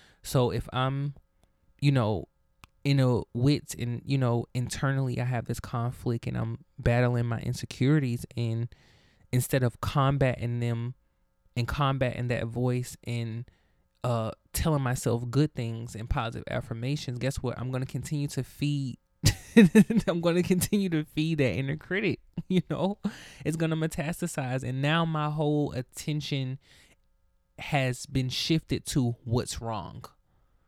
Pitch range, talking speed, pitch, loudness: 120-150 Hz, 135 wpm, 130 Hz, -29 LUFS